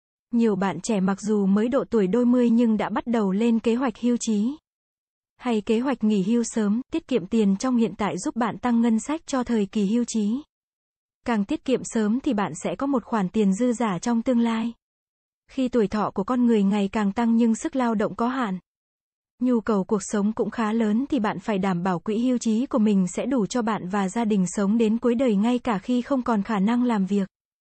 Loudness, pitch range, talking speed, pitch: -24 LUFS, 210-245 Hz, 235 wpm, 230 Hz